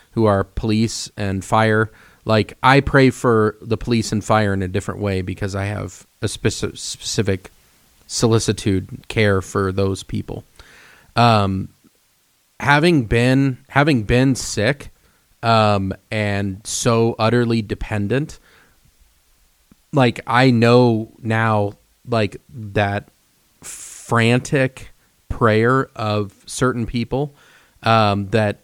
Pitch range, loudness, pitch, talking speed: 100-120 Hz, -18 LUFS, 110 Hz, 105 wpm